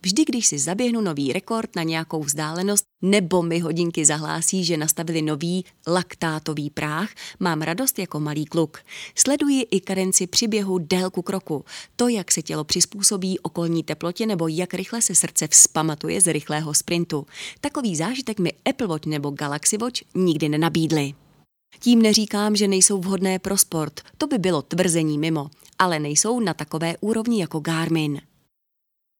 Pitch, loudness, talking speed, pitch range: 175 Hz, -21 LUFS, 150 wpm, 155-205 Hz